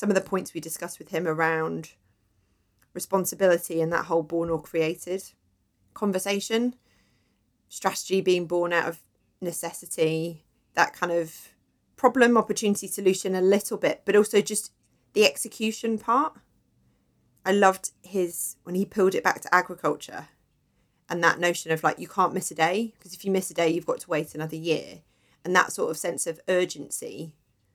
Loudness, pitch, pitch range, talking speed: -26 LUFS, 175 Hz, 160-195 Hz, 165 wpm